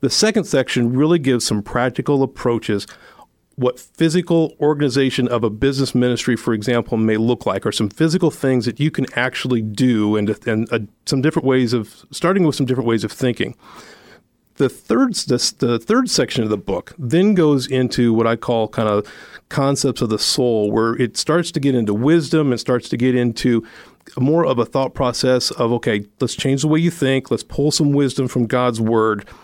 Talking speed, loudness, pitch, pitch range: 195 wpm, -18 LUFS, 125 Hz, 115-145 Hz